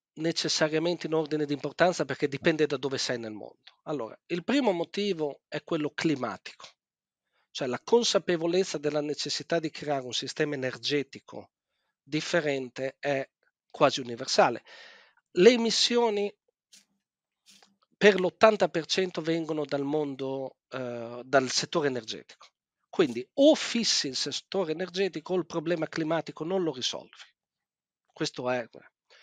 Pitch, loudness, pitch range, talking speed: 155 Hz, -28 LUFS, 140-180 Hz, 120 wpm